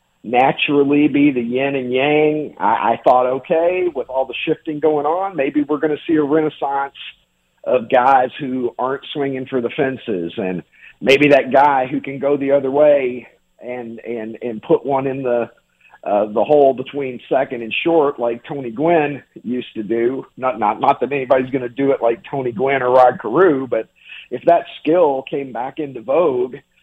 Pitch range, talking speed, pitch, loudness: 125-150 Hz, 190 wpm, 135 Hz, -17 LUFS